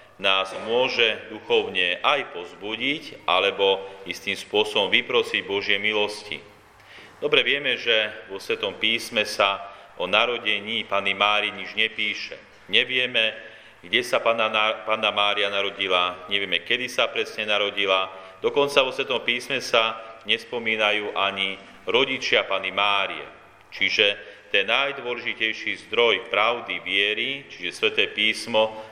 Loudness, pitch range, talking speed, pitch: -22 LUFS, 100-140 Hz, 110 wpm, 110 Hz